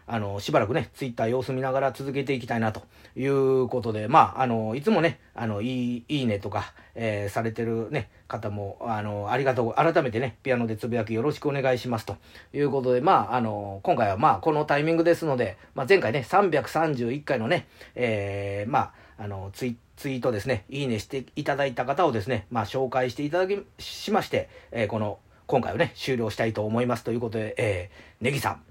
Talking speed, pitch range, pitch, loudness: 410 characters per minute, 110-135 Hz, 125 Hz, -26 LUFS